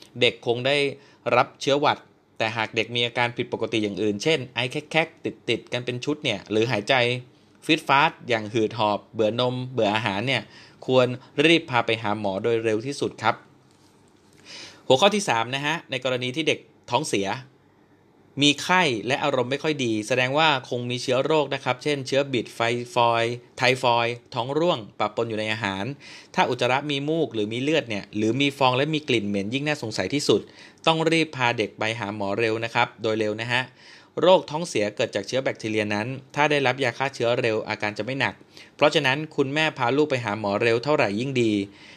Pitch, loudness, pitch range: 125 Hz, -23 LUFS, 110-140 Hz